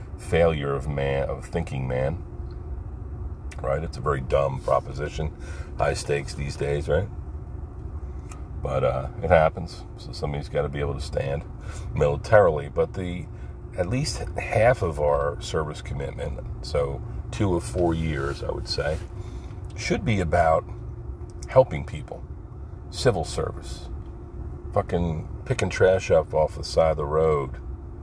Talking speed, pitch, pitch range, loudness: 135 wpm, 80 Hz, 70-90 Hz, -25 LUFS